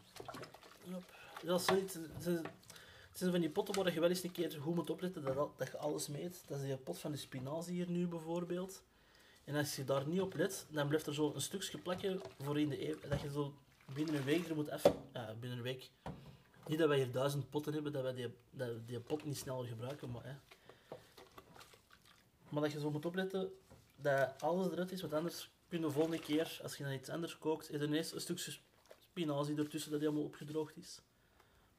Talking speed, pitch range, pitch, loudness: 225 wpm, 140-170 Hz, 150 Hz, -40 LUFS